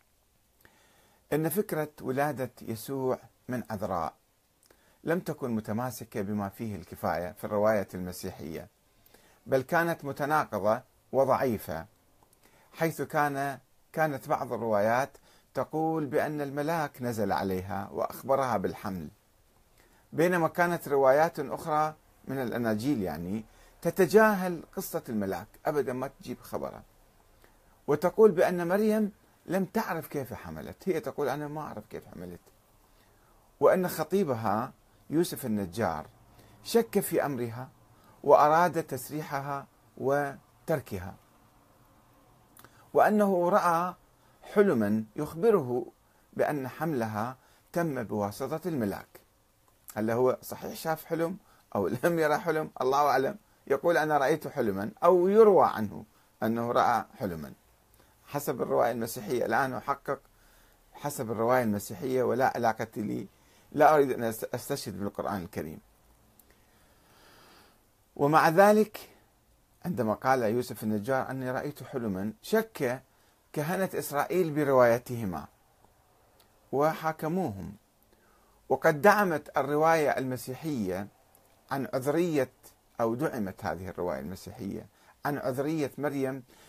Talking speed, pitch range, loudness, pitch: 100 wpm, 110-160 Hz, -29 LUFS, 130 Hz